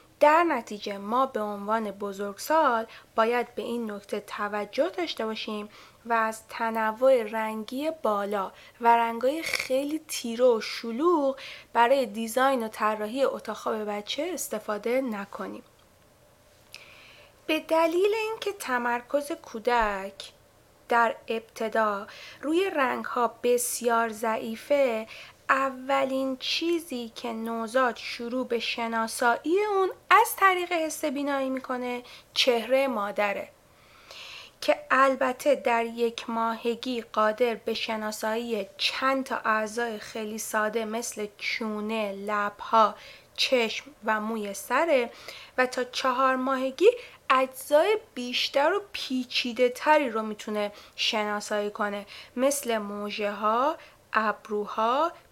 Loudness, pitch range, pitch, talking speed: -27 LUFS, 220-270 Hz, 235 Hz, 105 wpm